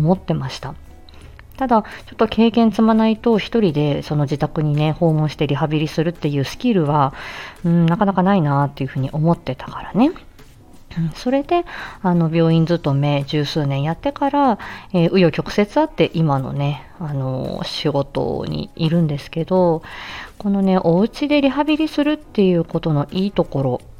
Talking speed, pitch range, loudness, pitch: 345 characters per minute, 145-210 Hz, -19 LUFS, 165 Hz